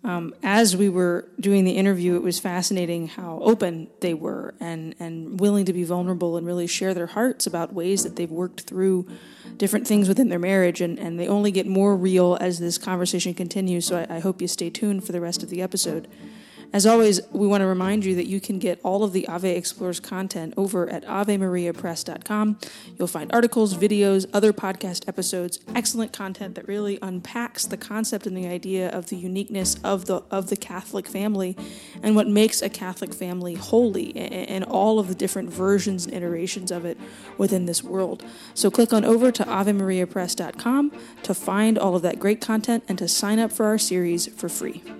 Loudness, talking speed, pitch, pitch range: -23 LUFS, 200 wpm, 190 Hz, 180-205 Hz